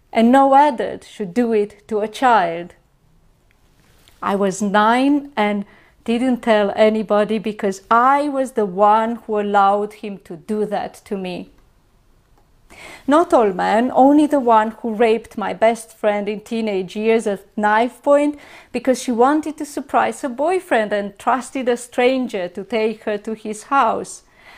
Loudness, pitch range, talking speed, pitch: -18 LUFS, 210-255 Hz, 155 wpm, 225 Hz